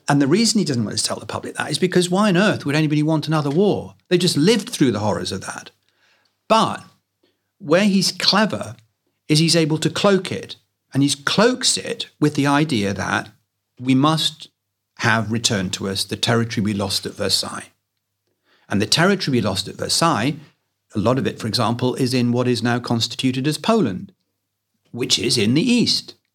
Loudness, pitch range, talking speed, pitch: -19 LUFS, 110-170 Hz, 195 wpm, 140 Hz